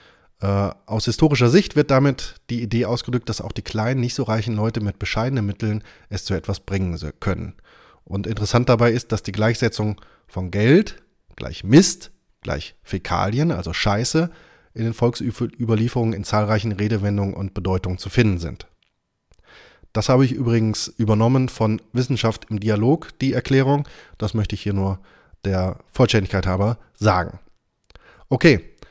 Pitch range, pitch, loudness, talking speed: 100-120 Hz, 110 Hz, -21 LUFS, 150 wpm